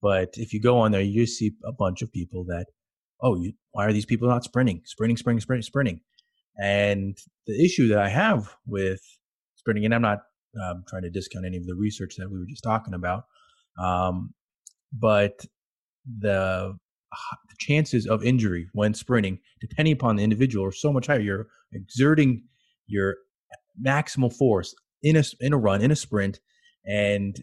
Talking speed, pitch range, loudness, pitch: 175 wpm, 100-125 Hz, -25 LUFS, 110 Hz